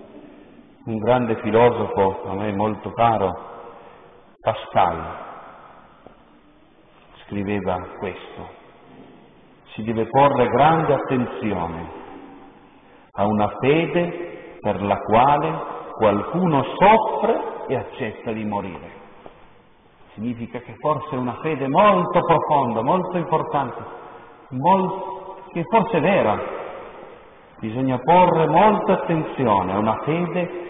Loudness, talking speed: -20 LUFS, 95 wpm